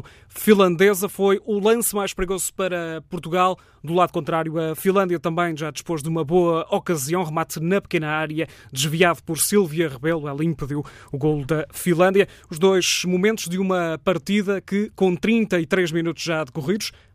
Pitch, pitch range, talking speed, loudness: 175 Hz, 160-195 Hz, 160 wpm, -21 LUFS